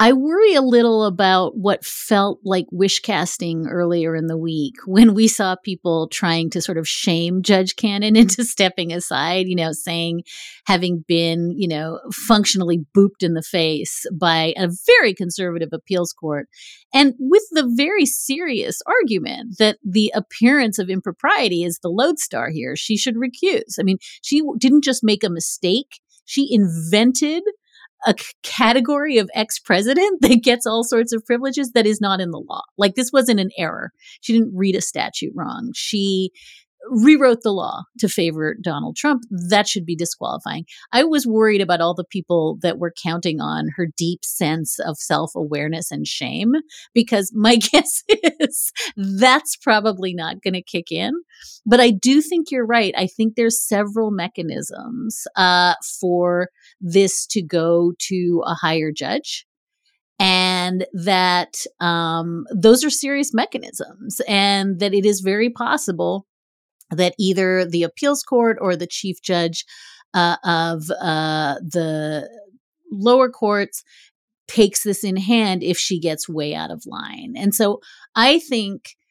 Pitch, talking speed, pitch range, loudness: 200 Hz, 155 wpm, 175-240 Hz, -18 LUFS